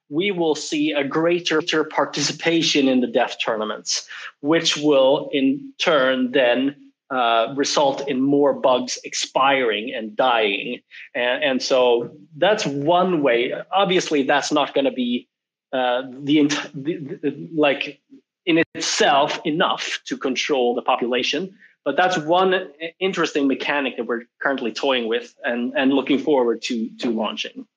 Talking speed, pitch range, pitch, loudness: 145 wpm, 135-185 Hz, 150 Hz, -20 LUFS